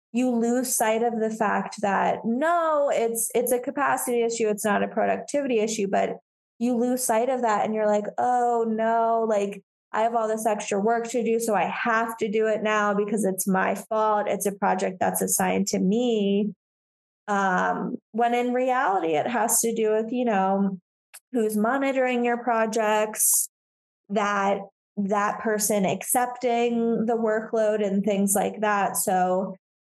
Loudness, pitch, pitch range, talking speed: -24 LUFS, 225 Hz, 210-240 Hz, 165 wpm